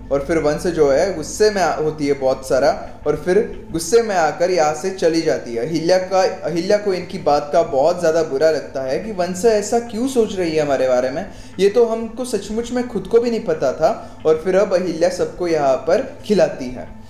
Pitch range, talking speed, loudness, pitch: 150-210 Hz, 220 wpm, -18 LUFS, 175 Hz